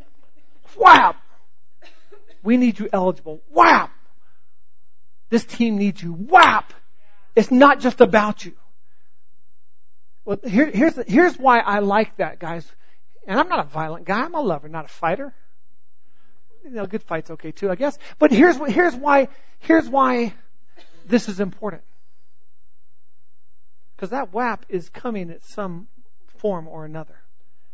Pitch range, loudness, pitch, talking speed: 155-245 Hz, -18 LUFS, 200 Hz, 140 wpm